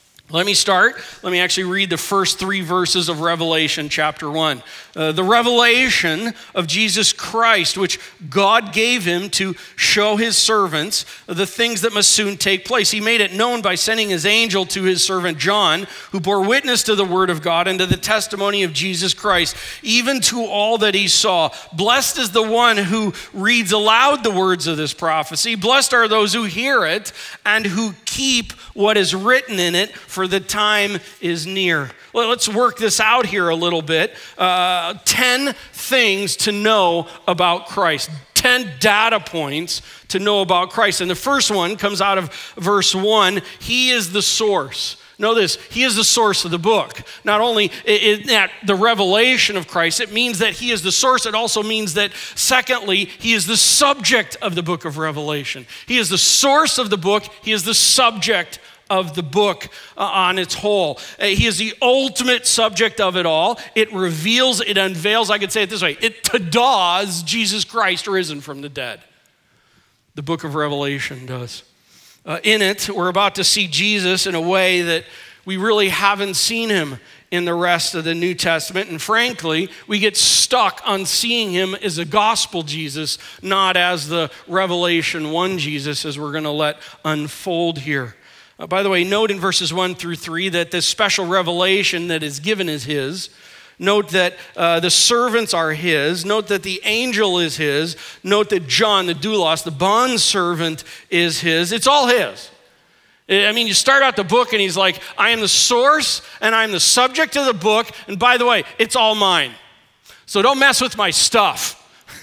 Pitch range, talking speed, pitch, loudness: 175-220 Hz, 185 wpm, 195 Hz, -16 LUFS